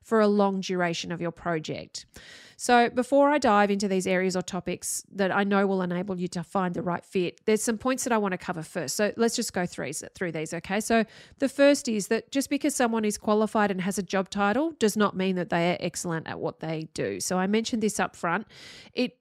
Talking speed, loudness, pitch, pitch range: 240 wpm, -27 LUFS, 200 Hz, 180-225 Hz